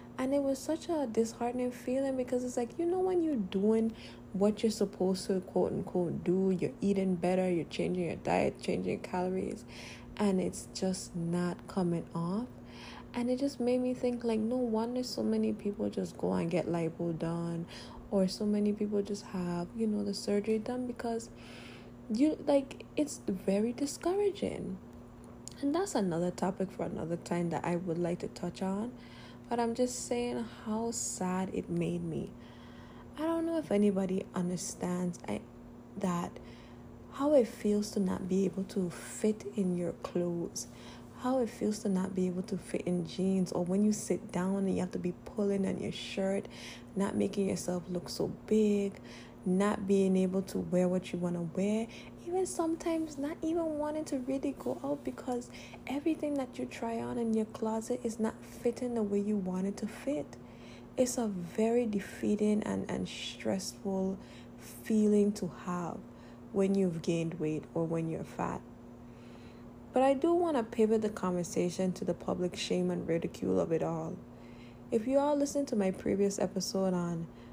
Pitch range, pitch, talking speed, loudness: 175-235 Hz, 200 Hz, 175 wpm, -33 LUFS